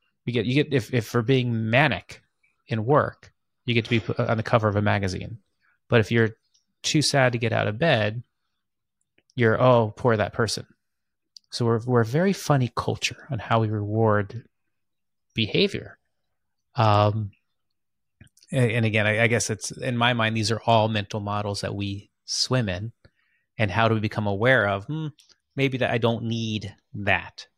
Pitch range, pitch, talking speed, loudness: 105-125 Hz, 115 Hz, 180 wpm, -23 LUFS